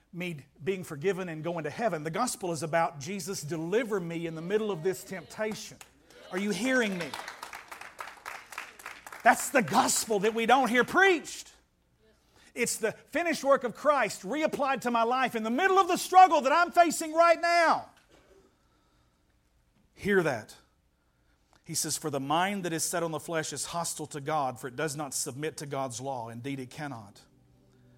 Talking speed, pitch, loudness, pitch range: 175 wpm, 185 Hz, -28 LUFS, 155-245 Hz